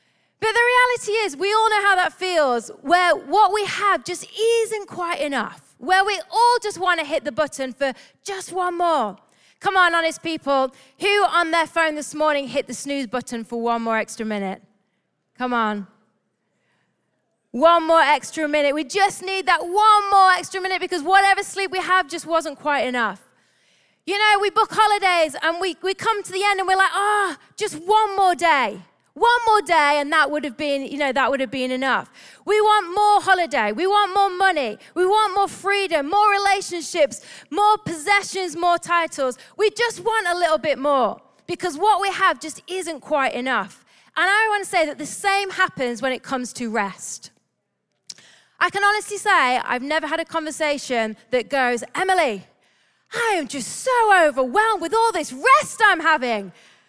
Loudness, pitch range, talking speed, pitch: -20 LUFS, 280-400 Hz, 190 wpm, 345 Hz